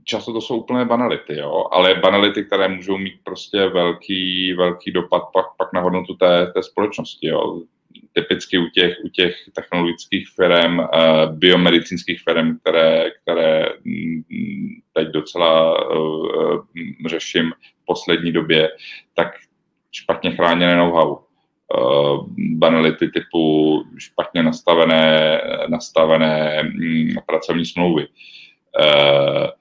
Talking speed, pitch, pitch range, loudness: 115 wpm, 85 Hz, 80-95 Hz, -17 LUFS